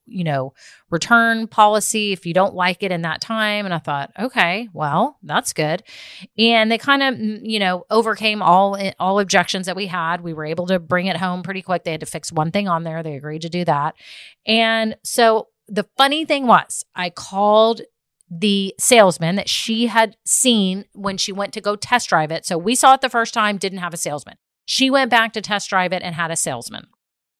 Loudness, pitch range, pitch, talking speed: -18 LUFS, 175-225 Hz, 195 Hz, 215 wpm